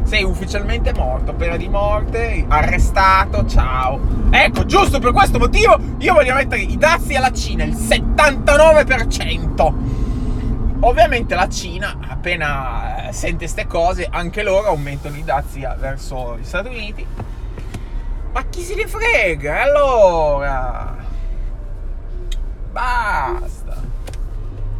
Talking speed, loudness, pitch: 110 wpm, -16 LUFS, 125 Hz